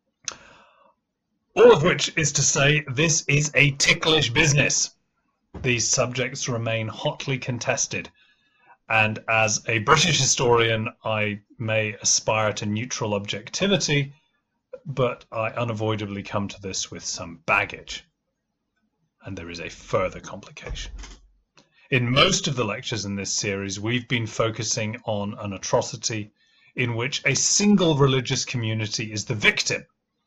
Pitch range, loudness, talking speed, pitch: 105-140 Hz, -22 LUFS, 130 wpm, 120 Hz